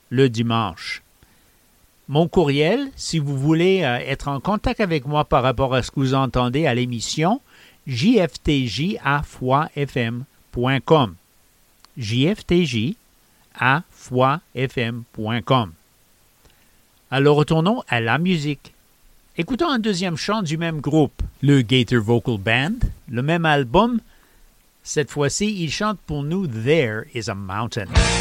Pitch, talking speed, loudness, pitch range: 140 Hz, 115 wpm, -20 LUFS, 120-165 Hz